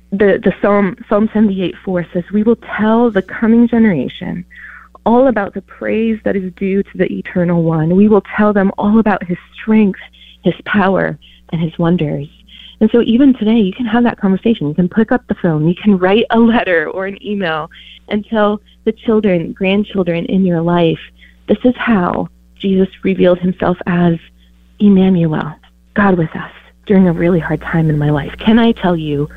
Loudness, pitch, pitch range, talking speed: -14 LUFS, 190 Hz, 170-215 Hz, 190 wpm